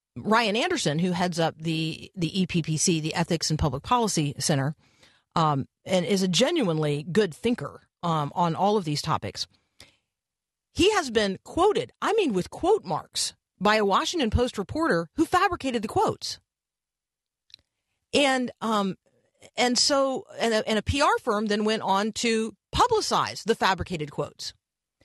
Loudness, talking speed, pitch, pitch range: -25 LUFS, 145 wpm, 200 Hz, 165-240 Hz